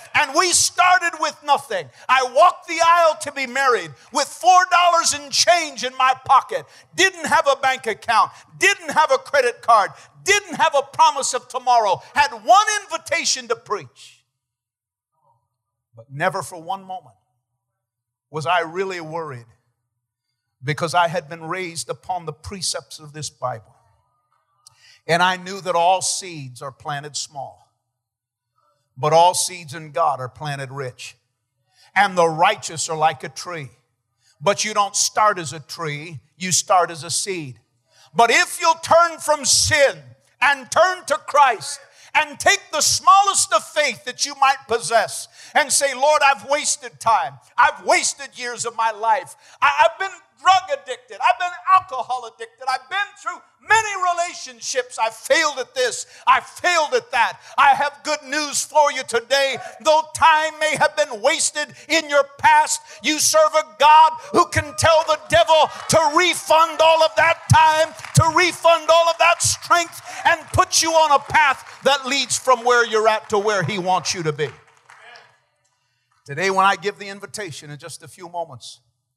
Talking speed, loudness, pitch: 165 wpm, -18 LUFS, 255 Hz